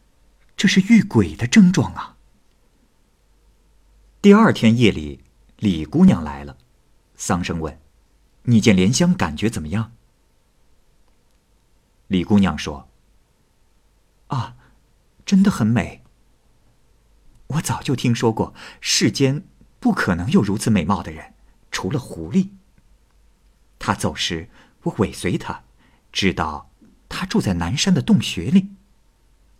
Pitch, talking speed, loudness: 110 Hz, 160 characters per minute, -19 LUFS